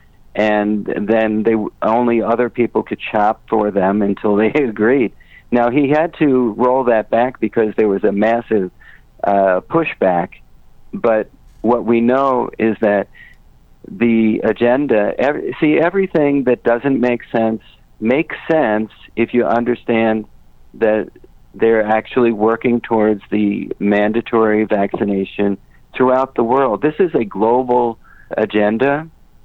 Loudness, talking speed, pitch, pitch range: -16 LUFS, 130 wpm, 115 Hz, 105-125 Hz